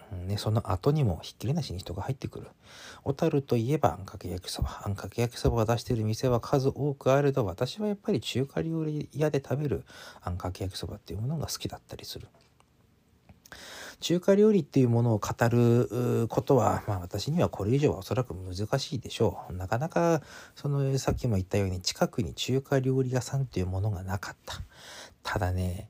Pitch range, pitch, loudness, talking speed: 100-140 Hz, 120 Hz, -29 LUFS, 400 characters per minute